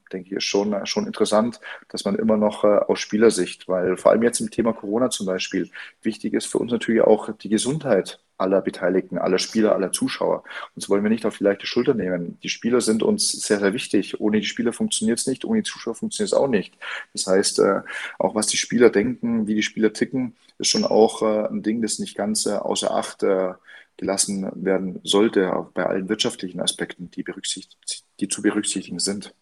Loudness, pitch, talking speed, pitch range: -22 LUFS, 110 Hz, 205 wpm, 100-120 Hz